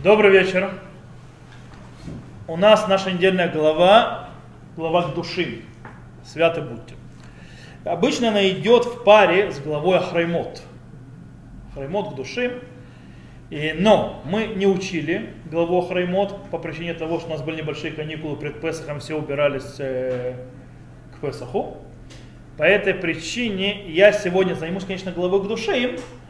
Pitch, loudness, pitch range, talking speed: 170 Hz, -20 LUFS, 150-195 Hz, 125 wpm